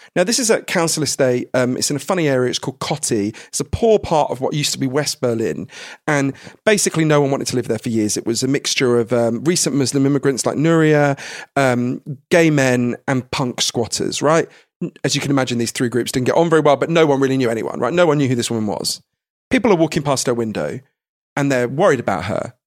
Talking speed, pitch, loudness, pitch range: 240 wpm, 140 Hz, -18 LUFS, 125-155 Hz